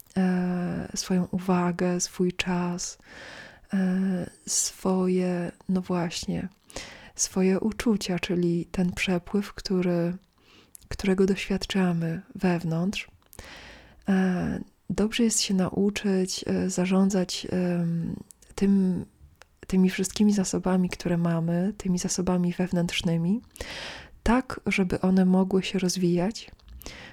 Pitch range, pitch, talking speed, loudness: 180-195 Hz, 185 Hz, 75 wpm, -26 LUFS